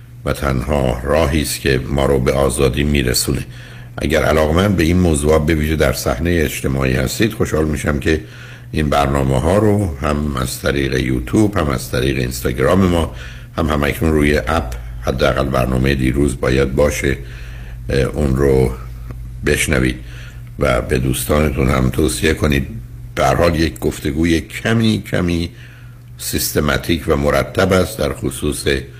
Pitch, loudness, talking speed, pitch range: 75 Hz, -16 LUFS, 135 wpm, 65-85 Hz